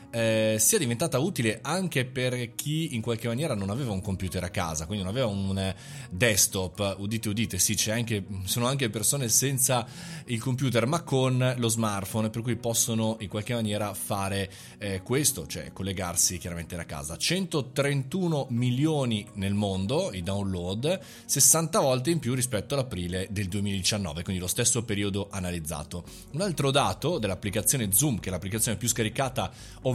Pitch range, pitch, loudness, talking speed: 95-130 Hz, 110 Hz, -27 LUFS, 160 wpm